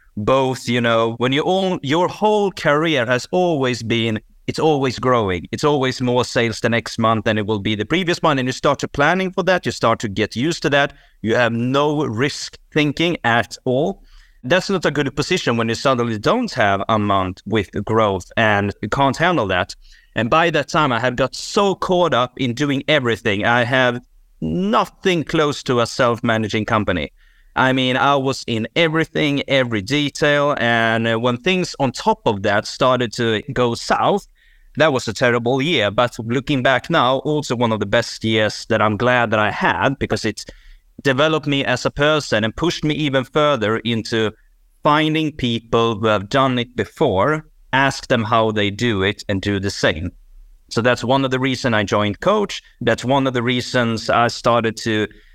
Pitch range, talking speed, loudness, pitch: 115-145 Hz, 195 wpm, -18 LUFS, 125 Hz